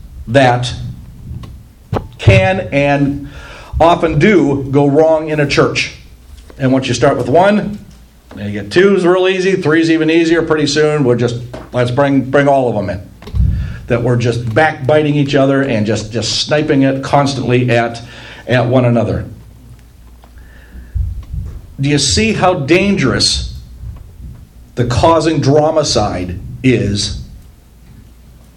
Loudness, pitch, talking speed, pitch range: -13 LUFS, 125 Hz, 130 wpm, 105-150 Hz